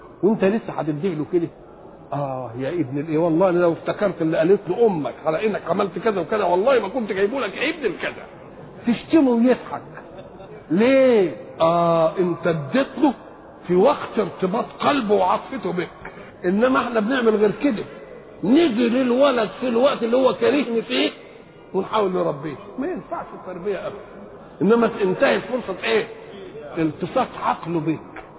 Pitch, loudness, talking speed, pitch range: 200 Hz, -21 LUFS, 140 wpm, 170-240 Hz